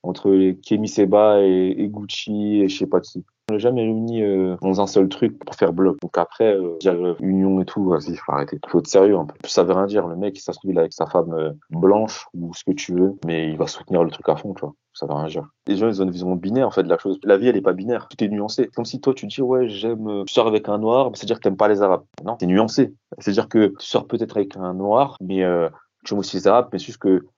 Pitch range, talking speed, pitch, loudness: 95-110 Hz, 290 wpm, 100 Hz, -20 LUFS